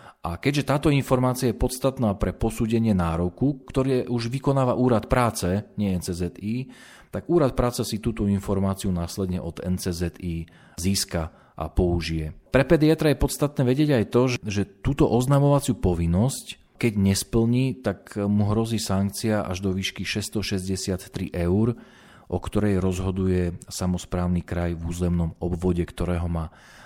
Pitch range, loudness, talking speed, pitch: 90-125 Hz, -24 LUFS, 135 wpm, 100 Hz